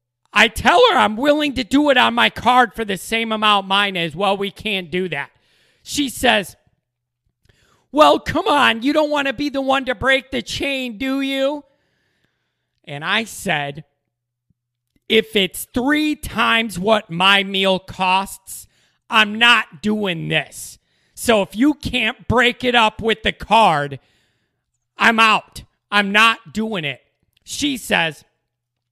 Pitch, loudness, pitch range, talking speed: 210 Hz, -17 LUFS, 160-250 Hz, 150 wpm